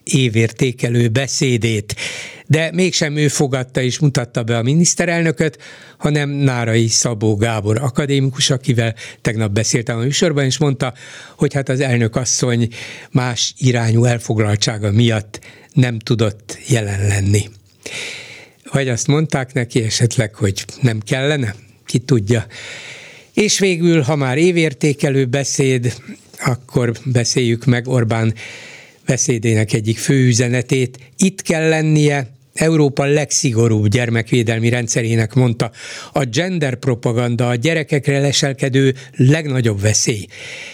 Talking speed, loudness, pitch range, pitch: 110 wpm, -16 LUFS, 115-145 Hz, 130 Hz